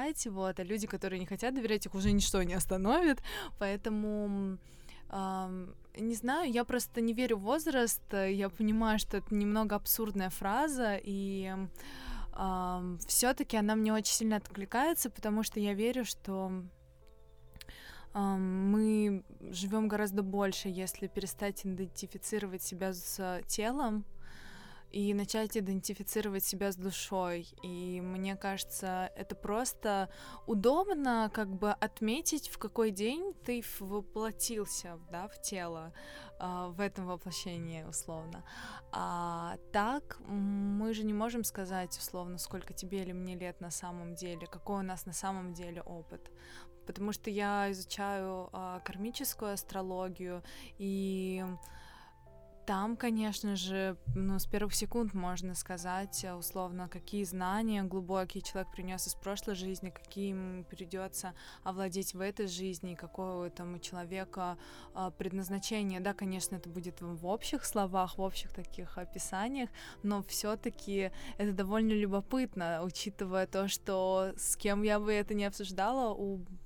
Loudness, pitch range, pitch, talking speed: -36 LUFS, 185-210 Hz, 195 Hz, 130 wpm